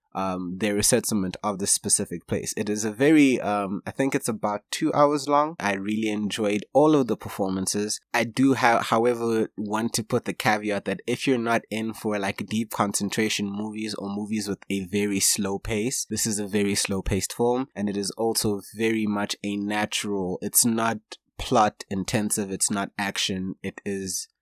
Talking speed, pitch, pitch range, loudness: 185 wpm, 105 Hz, 100-115 Hz, -25 LUFS